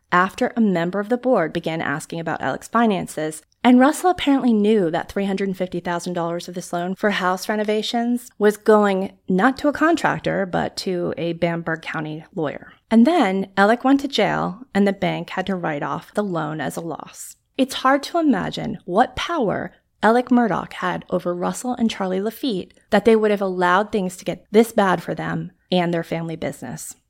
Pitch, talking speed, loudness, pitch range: 200 Hz, 185 wpm, -21 LUFS, 175-235 Hz